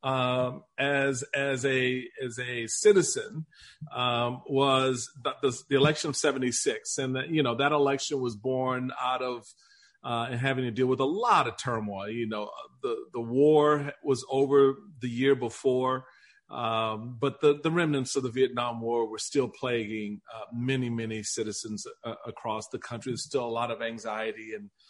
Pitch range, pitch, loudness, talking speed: 120-140 Hz, 130 Hz, -28 LUFS, 170 wpm